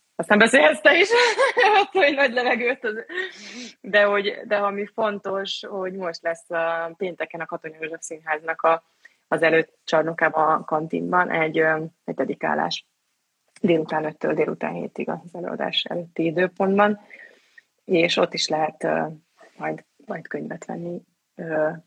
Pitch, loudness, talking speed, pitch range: 175 Hz, -22 LUFS, 125 wpm, 160-225 Hz